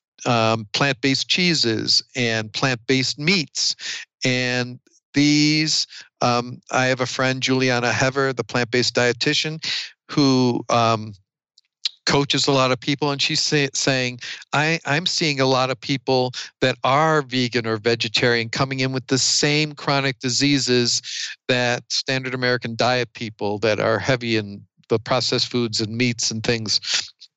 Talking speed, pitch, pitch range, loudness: 145 wpm, 130 Hz, 120-140 Hz, -20 LUFS